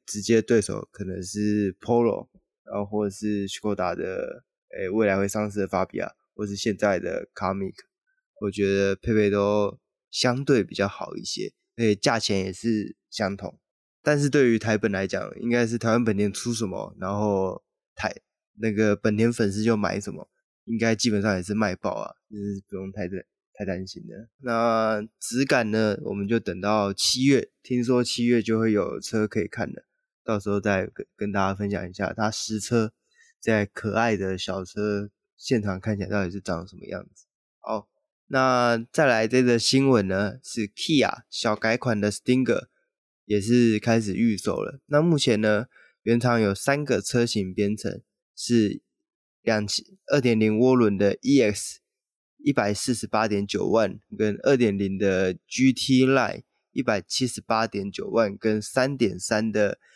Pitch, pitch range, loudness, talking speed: 110 Hz, 100-120 Hz, -25 LUFS, 255 characters per minute